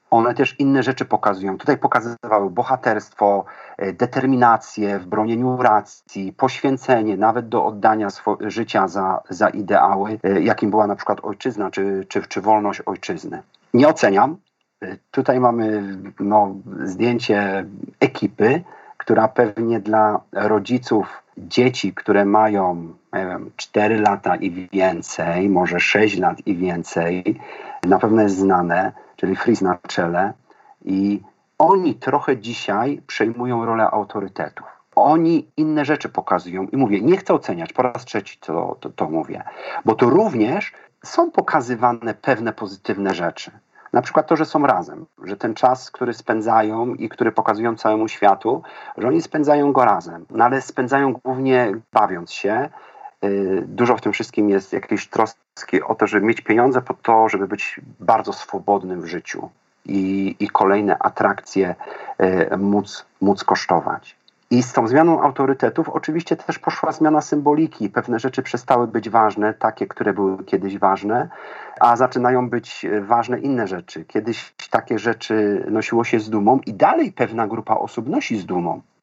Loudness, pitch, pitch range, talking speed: -19 LUFS, 110 Hz, 100-130 Hz, 145 wpm